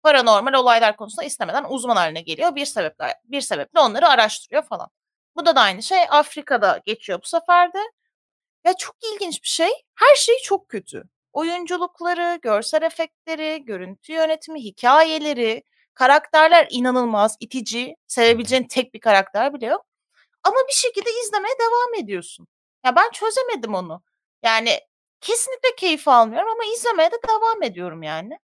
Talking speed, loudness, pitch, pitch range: 145 wpm, -19 LUFS, 310 Hz, 235-365 Hz